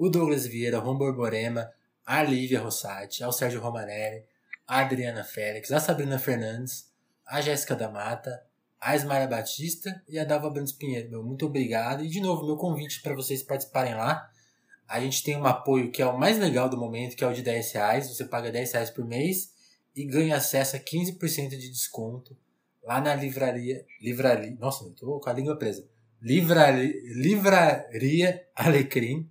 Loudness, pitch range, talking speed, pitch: -27 LUFS, 120-150 Hz, 170 wpm, 130 Hz